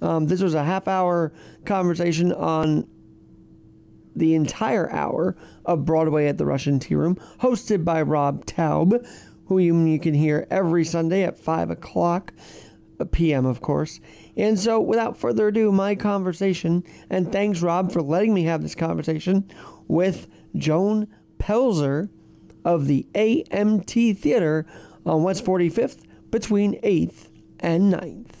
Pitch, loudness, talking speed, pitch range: 175 Hz, -22 LUFS, 135 wpm, 160-195 Hz